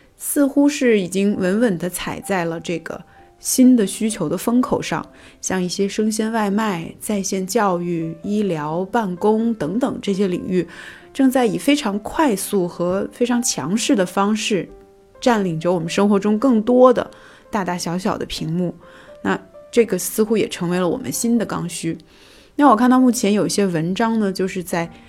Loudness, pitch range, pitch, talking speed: -19 LUFS, 180-235 Hz, 205 Hz, 250 characters per minute